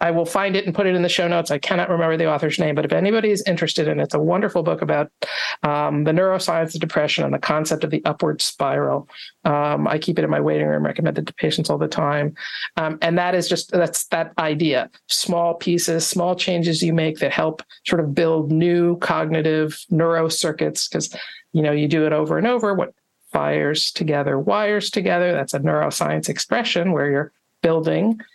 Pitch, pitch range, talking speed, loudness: 165 Hz, 155-180 Hz, 210 wpm, -20 LUFS